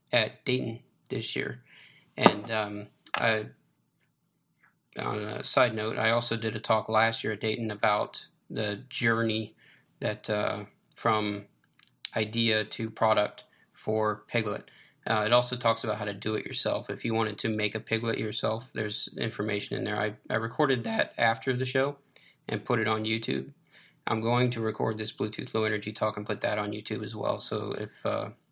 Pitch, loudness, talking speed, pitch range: 110 Hz, -29 LUFS, 175 wpm, 105-115 Hz